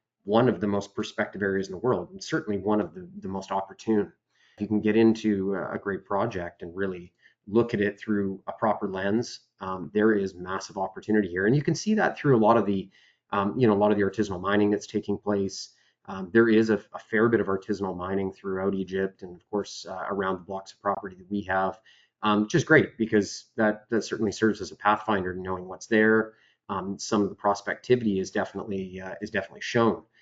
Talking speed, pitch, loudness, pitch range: 220 wpm, 100 Hz, -27 LUFS, 95-110 Hz